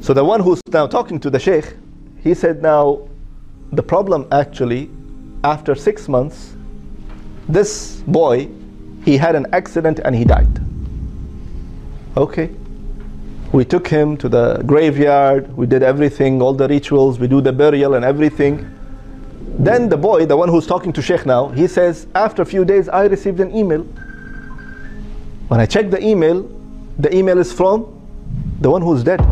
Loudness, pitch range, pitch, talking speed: -15 LUFS, 120-175 Hz, 145 Hz, 160 wpm